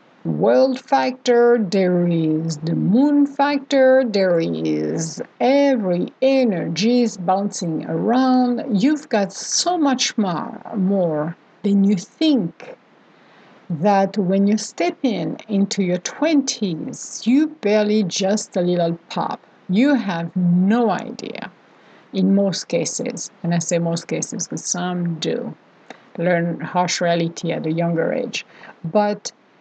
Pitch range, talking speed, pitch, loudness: 175-250 Hz, 120 wpm, 200 Hz, -19 LUFS